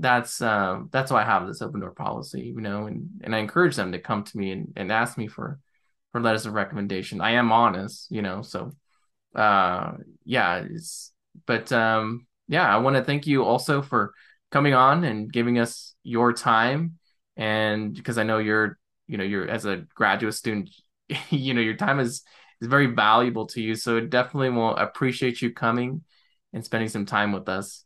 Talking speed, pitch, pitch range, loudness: 195 wpm, 115 Hz, 110-130 Hz, -24 LUFS